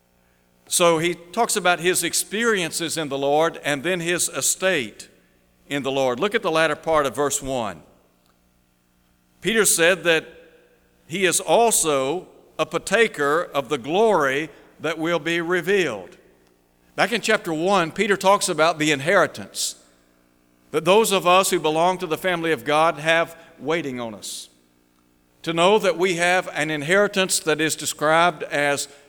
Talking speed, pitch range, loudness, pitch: 155 wpm, 125-175 Hz, -20 LUFS, 160 Hz